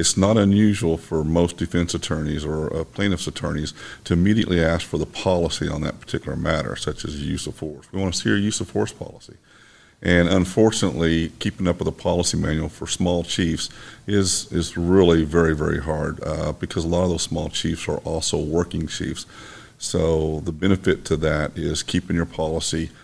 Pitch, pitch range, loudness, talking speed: 85 Hz, 80-95 Hz, -22 LUFS, 190 wpm